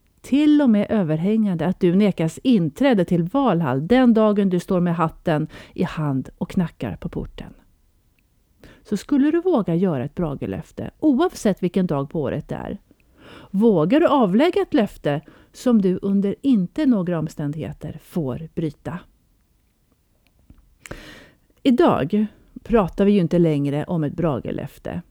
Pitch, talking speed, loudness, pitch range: 185 Hz, 140 wpm, -20 LUFS, 160-225 Hz